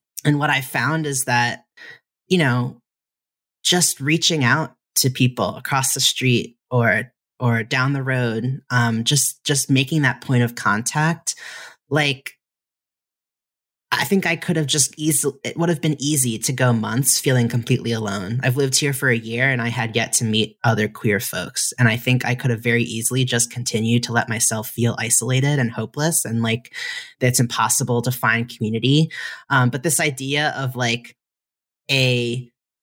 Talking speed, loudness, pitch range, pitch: 170 wpm, -19 LUFS, 120-145 Hz, 125 Hz